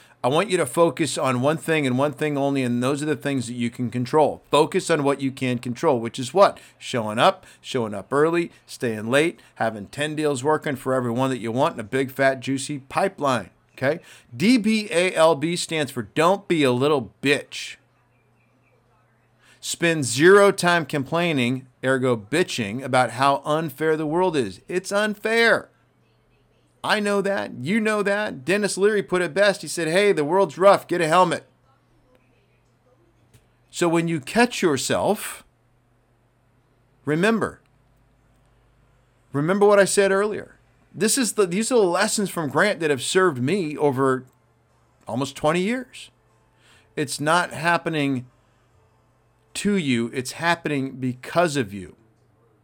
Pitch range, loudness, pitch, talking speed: 125-170 Hz, -22 LUFS, 140 Hz, 150 wpm